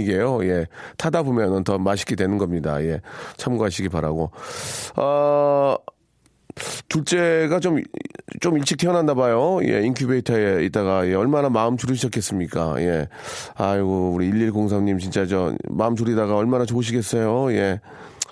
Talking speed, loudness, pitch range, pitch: 300 characters per minute, -21 LUFS, 95-140 Hz, 110 Hz